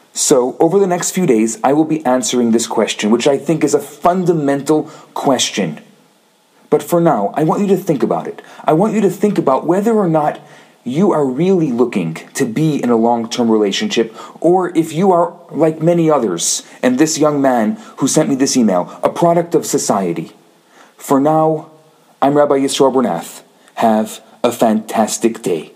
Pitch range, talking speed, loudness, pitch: 130-170 Hz, 180 wpm, -15 LUFS, 155 Hz